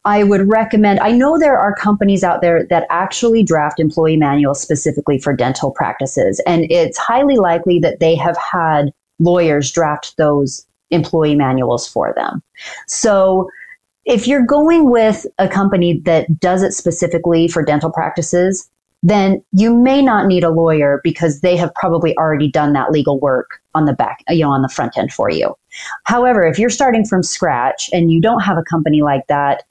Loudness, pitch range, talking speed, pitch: -14 LUFS, 155-205 Hz, 180 wpm, 170 Hz